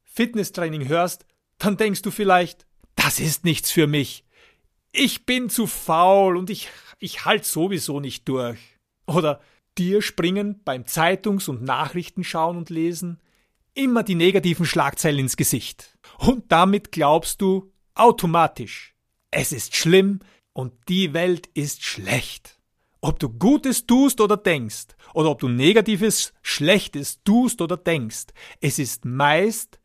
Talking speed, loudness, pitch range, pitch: 135 wpm, -21 LUFS, 145-205 Hz, 175 Hz